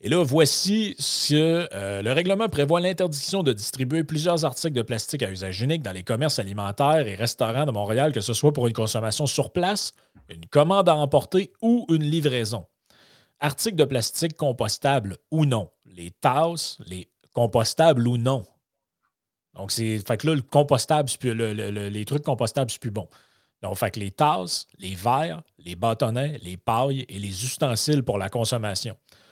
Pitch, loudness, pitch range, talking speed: 130 Hz, -24 LUFS, 110-155 Hz, 170 wpm